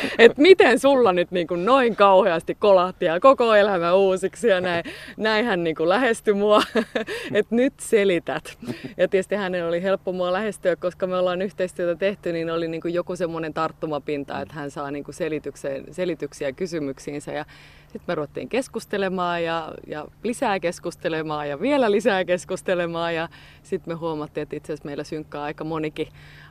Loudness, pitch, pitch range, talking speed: -22 LUFS, 180 Hz, 160-200 Hz, 160 wpm